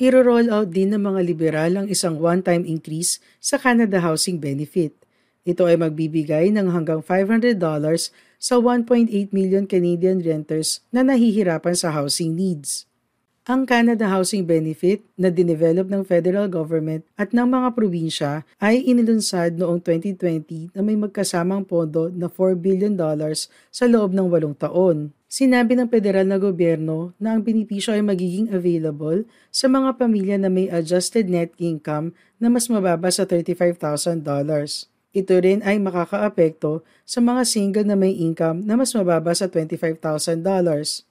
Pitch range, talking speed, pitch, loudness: 165-205 Hz, 145 wpm, 180 Hz, -20 LUFS